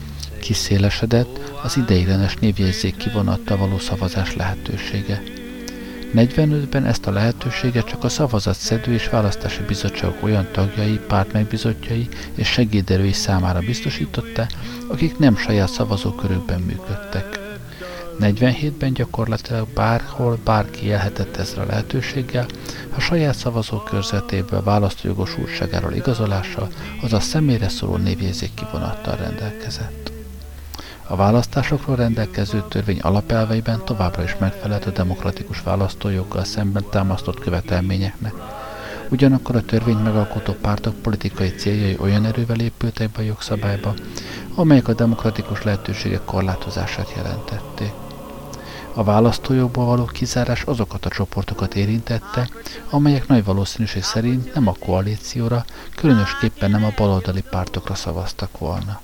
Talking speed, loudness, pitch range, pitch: 110 wpm, -21 LUFS, 100-120 Hz, 105 Hz